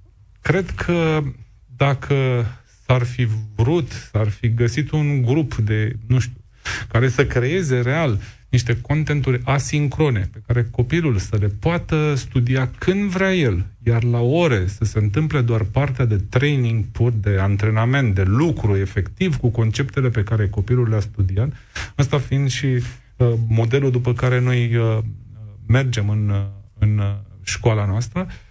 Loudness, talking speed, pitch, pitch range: -20 LUFS, 140 wpm, 120 Hz, 110-135 Hz